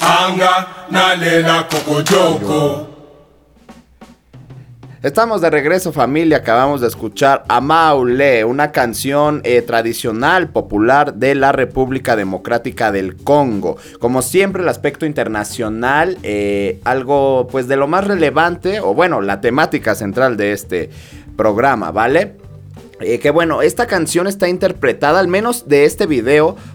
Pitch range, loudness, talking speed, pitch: 125-165 Hz, -14 LUFS, 115 wpm, 145 Hz